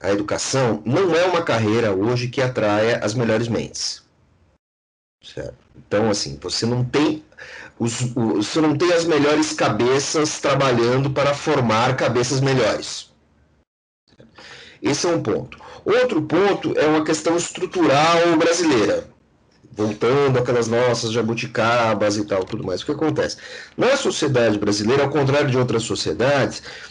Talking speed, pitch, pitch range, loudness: 140 wpm, 125 Hz, 110-150 Hz, -19 LUFS